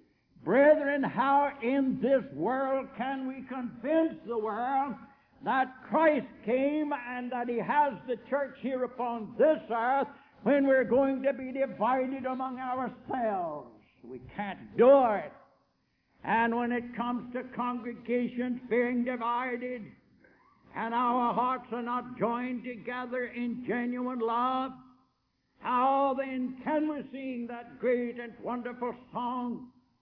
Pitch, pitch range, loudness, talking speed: 250 Hz, 240-265 Hz, -30 LUFS, 125 wpm